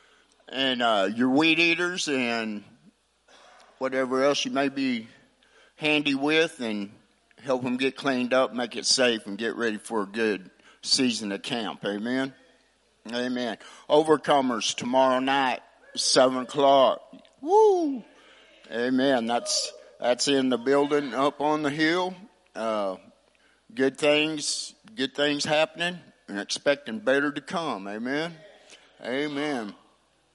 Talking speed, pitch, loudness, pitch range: 125 wpm, 135 Hz, -25 LUFS, 125-150 Hz